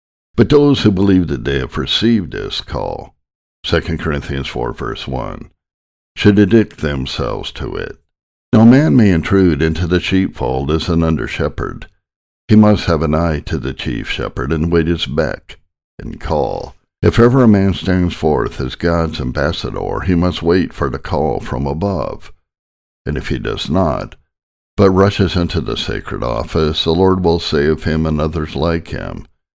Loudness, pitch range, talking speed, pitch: -15 LUFS, 75-95 Hz, 165 wpm, 85 Hz